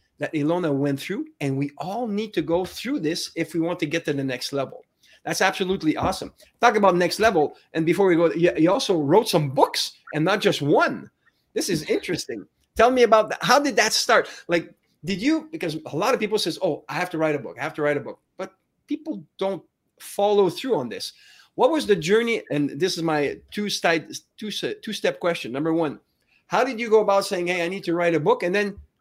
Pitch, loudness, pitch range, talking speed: 175 Hz, -23 LUFS, 155-210 Hz, 230 wpm